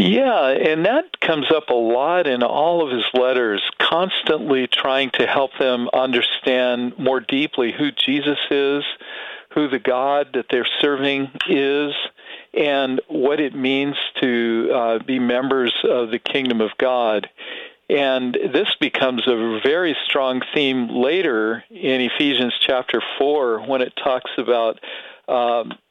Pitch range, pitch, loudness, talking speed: 125-145 Hz, 130 Hz, -19 LUFS, 140 wpm